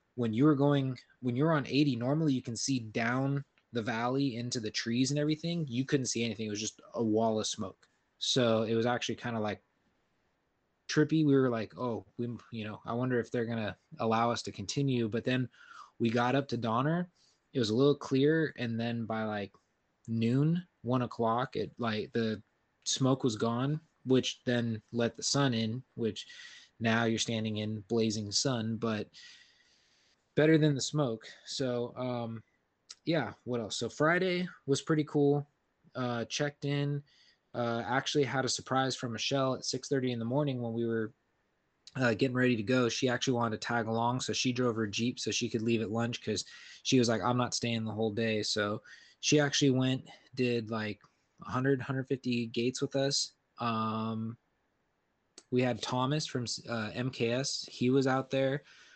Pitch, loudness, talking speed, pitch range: 120 Hz, -32 LUFS, 185 wpm, 115-135 Hz